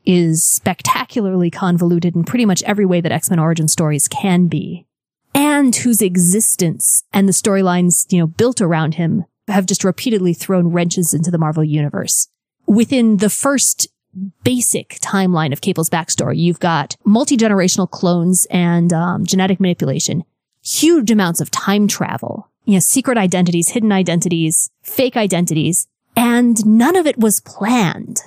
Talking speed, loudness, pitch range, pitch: 150 wpm, -15 LUFS, 170-215 Hz, 185 Hz